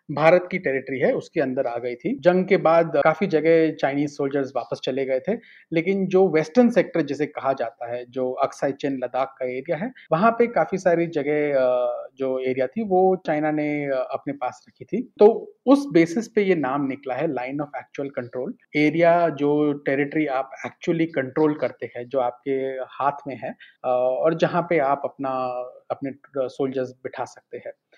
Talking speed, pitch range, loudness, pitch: 180 wpm, 130-170 Hz, -23 LUFS, 145 Hz